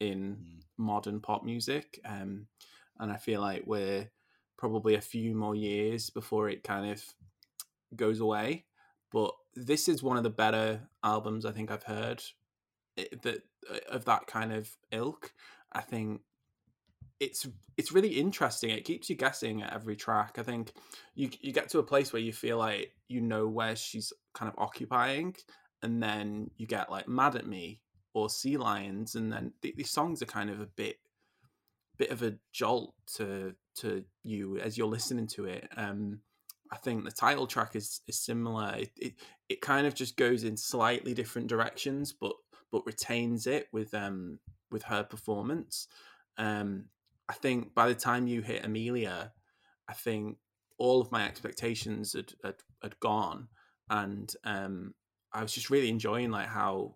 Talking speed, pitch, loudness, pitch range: 170 wpm, 110 Hz, -34 LUFS, 105-120 Hz